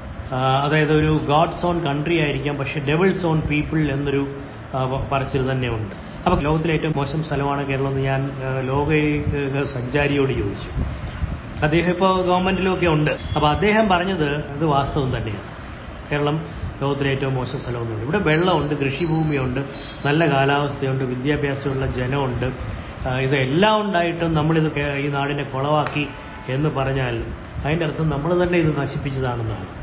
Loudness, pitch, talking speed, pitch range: -21 LUFS, 140 Hz, 120 wpm, 135-155 Hz